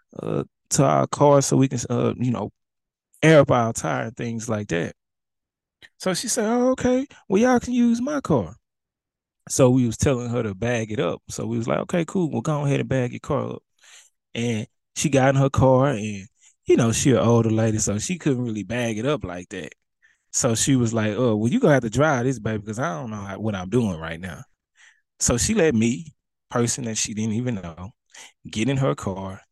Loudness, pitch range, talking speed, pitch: -22 LUFS, 110-140 Hz, 225 wpm, 120 Hz